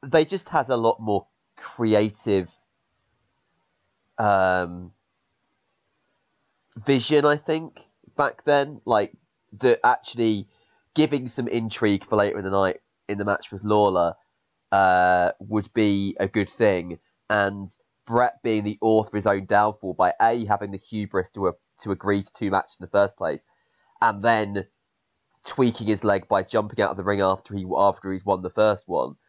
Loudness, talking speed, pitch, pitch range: -23 LUFS, 160 wpm, 105 Hz, 100-115 Hz